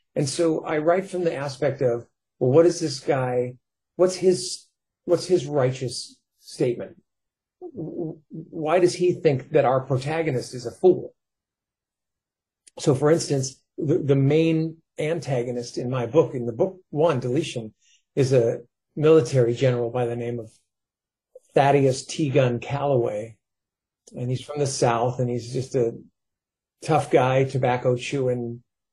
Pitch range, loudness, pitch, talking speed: 125-165 Hz, -23 LUFS, 140 Hz, 145 wpm